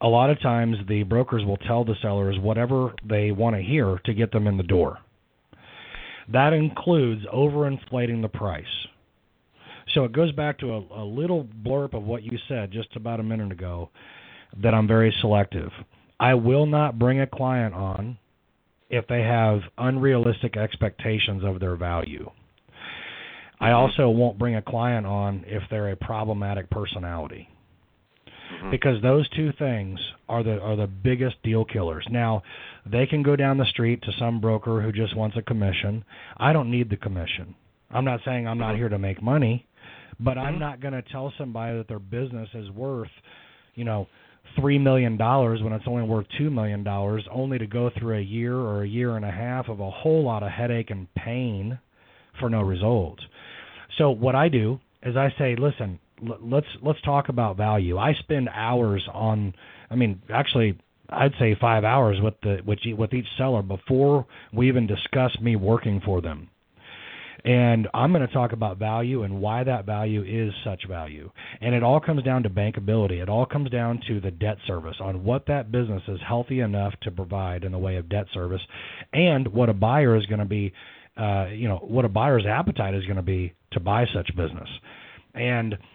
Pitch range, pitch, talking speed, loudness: 100-125 Hz, 115 Hz, 185 wpm, -24 LUFS